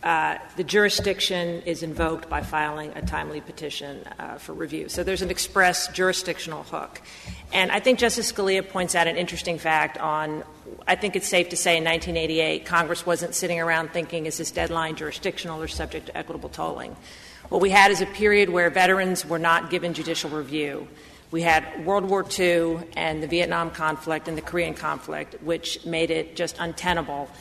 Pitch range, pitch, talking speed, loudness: 160-185 Hz, 170 Hz, 180 wpm, -24 LUFS